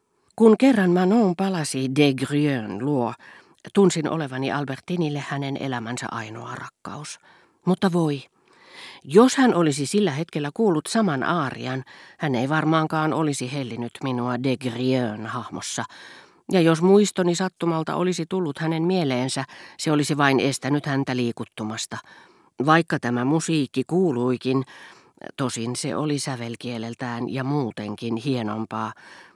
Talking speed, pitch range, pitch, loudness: 115 wpm, 125-170 Hz, 140 Hz, -23 LUFS